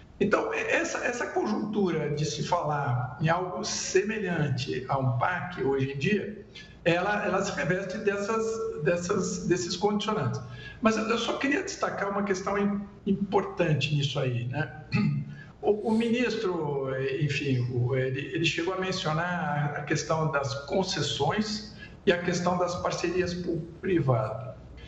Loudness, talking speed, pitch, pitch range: -28 LUFS, 130 wpm, 175 Hz, 145-200 Hz